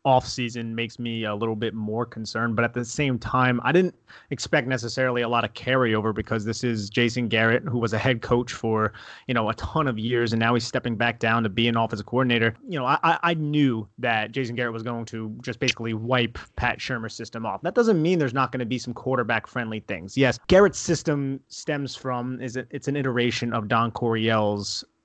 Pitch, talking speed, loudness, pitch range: 120 Hz, 220 wpm, -24 LUFS, 115-130 Hz